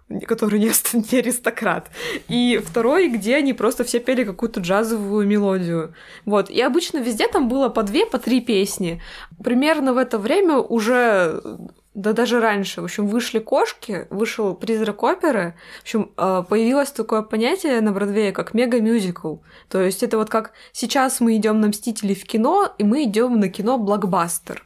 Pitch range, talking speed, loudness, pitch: 205-250 Hz, 160 wpm, -20 LUFS, 225 Hz